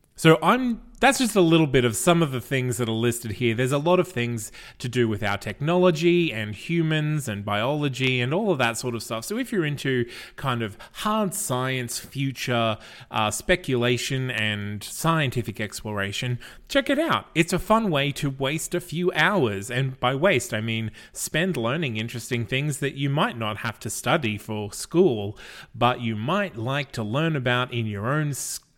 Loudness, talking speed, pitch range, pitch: -24 LUFS, 190 wpm, 115-165 Hz, 130 Hz